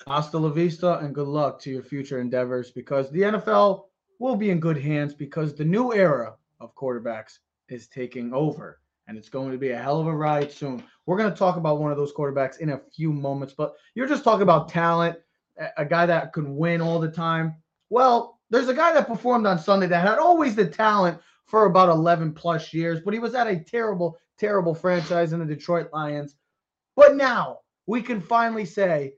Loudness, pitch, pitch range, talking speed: -23 LUFS, 165 Hz, 145-200 Hz, 210 wpm